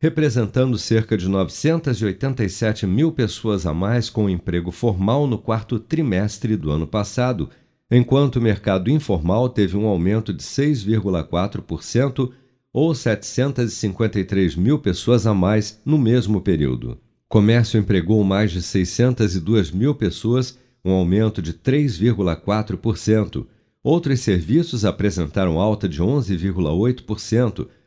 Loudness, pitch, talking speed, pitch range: -20 LUFS, 110 Hz, 115 wpm, 95-125 Hz